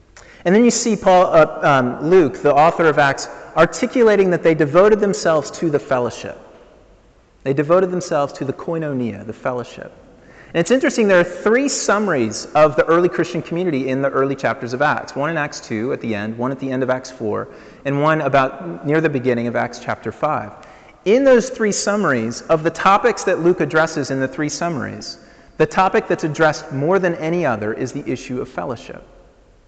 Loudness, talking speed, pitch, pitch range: -17 LUFS, 195 wpm, 160 Hz, 135-185 Hz